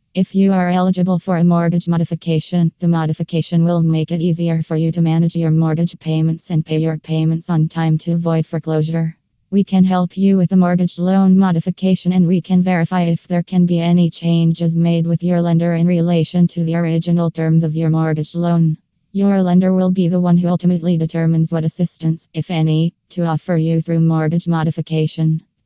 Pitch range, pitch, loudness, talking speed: 160-175 Hz, 170 Hz, -16 LUFS, 190 wpm